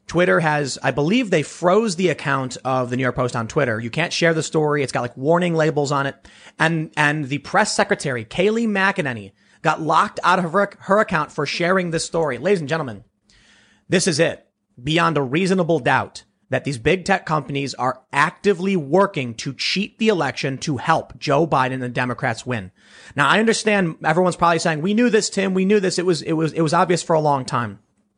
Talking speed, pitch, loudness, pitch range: 210 wpm, 160 Hz, -20 LUFS, 135-185 Hz